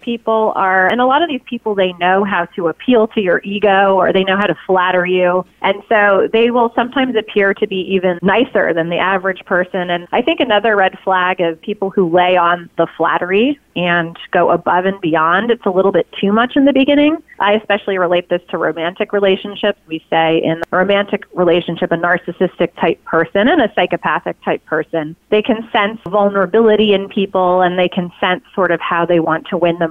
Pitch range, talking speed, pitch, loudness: 175-210 Hz, 210 wpm, 190 Hz, -14 LUFS